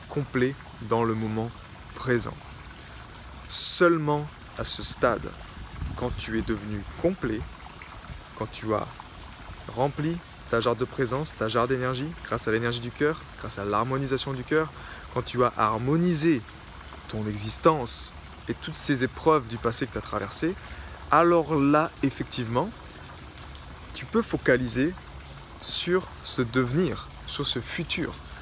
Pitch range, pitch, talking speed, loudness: 105-145 Hz, 120 Hz, 135 wpm, -26 LUFS